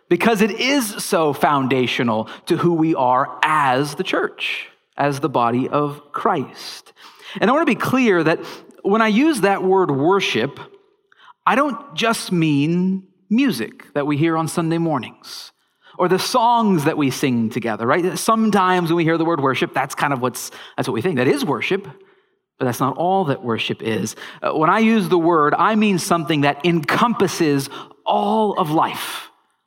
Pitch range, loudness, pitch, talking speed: 145-220 Hz, -19 LUFS, 175 Hz, 175 wpm